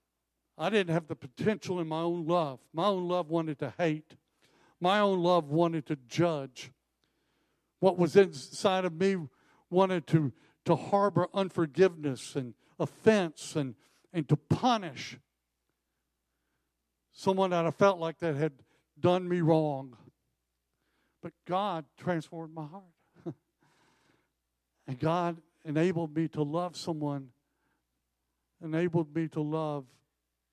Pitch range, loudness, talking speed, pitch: 135-175 Hz, -30 LUFS, 125 wpm, 160 Hz